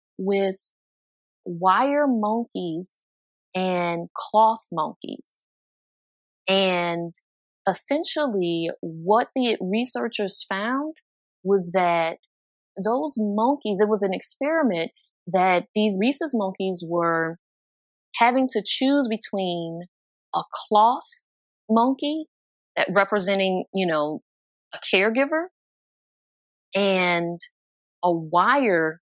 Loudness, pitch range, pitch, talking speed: -23 LUFS, 175-235 Hz, 195 Hz, 85 wpm